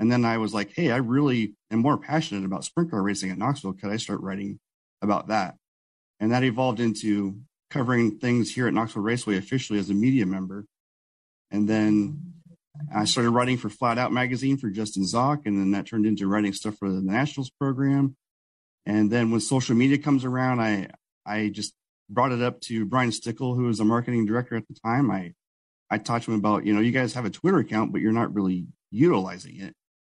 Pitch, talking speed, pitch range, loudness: 115 Hz, 210 wpm, 105-125 Hz, -25 LUFS